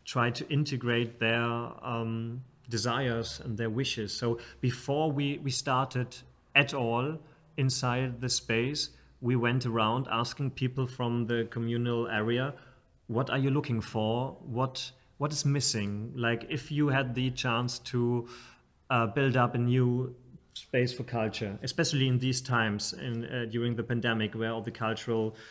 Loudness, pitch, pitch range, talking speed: -31 LUFS, 120 Hz, 115-130 Hz, 155 wpm